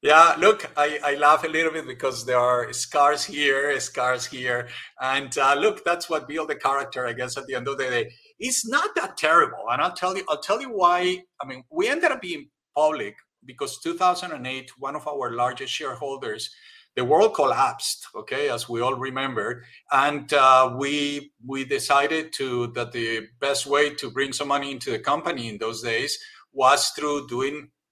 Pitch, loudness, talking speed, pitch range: 145 Hz, -23 LUFS, 190 wpm, 130-160 Hz